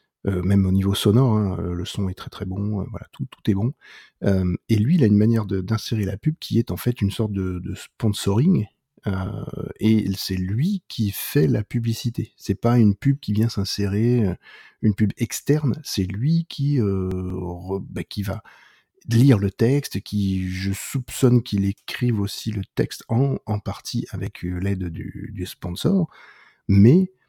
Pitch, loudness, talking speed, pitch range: 105 Hz, -22 LUFS, 185 wpm, 95-120 Hz